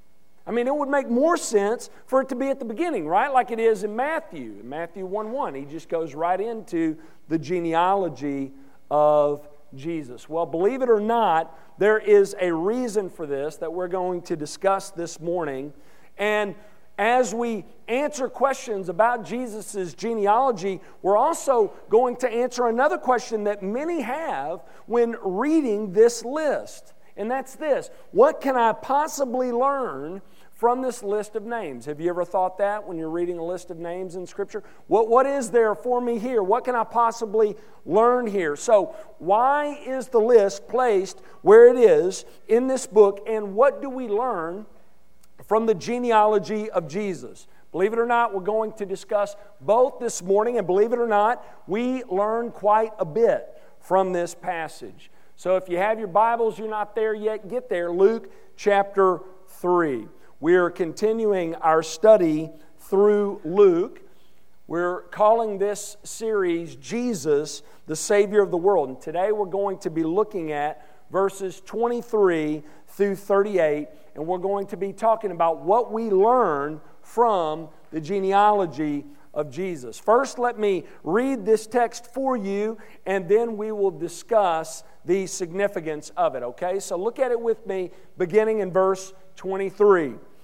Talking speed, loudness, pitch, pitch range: 165 wpm, -23 LUFS, 205 Hz, 175-235 Hz